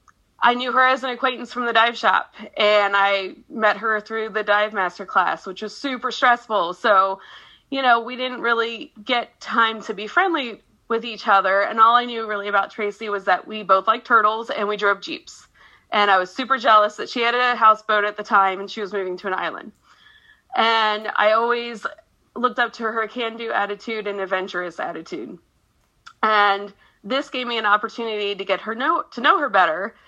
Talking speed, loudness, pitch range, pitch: 200 wpm, -20 LUFS, 205-240 Hz, 220 Hz